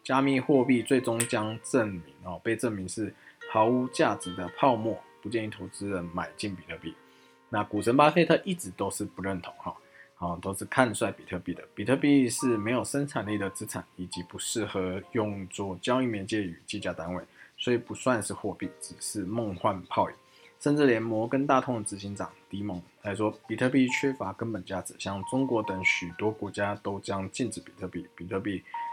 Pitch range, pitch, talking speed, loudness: 95-120 Hz, 105 Hz, 285 characters per minute, -29 LUFS